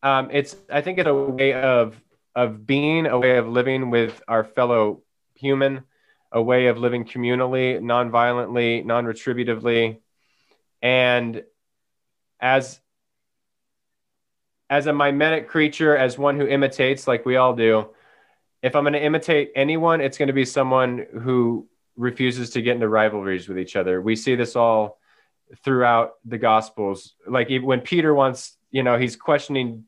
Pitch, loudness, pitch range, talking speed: 125 Hz, -21 LUFS, 115-135 Hz, 150 wpm